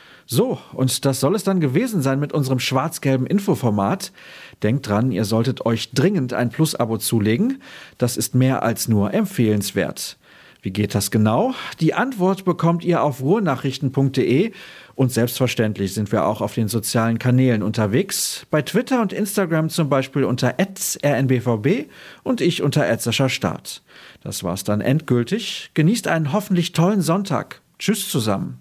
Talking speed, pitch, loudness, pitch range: 150 wpm, 135 Hz, -20 LUFS, 115-175 Hz